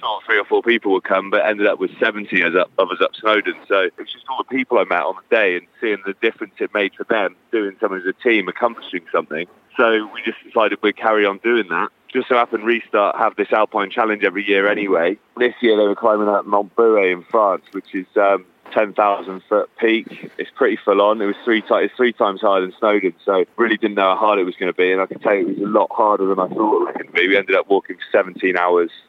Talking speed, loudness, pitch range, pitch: 265 wpm, -18 LUFS, 100-125 Hz, 105 Hz